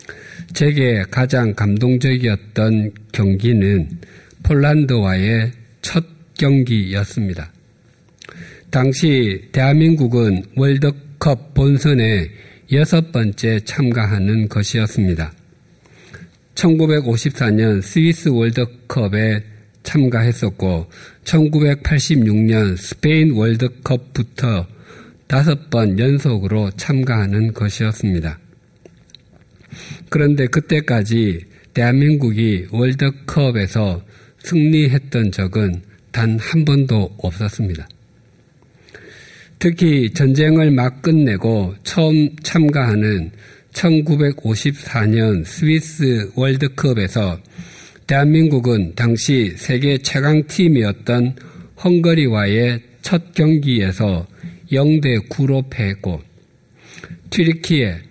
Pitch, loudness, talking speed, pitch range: 120 Hz, -16 LUFS, 185 characters per minute, 105-145 Hz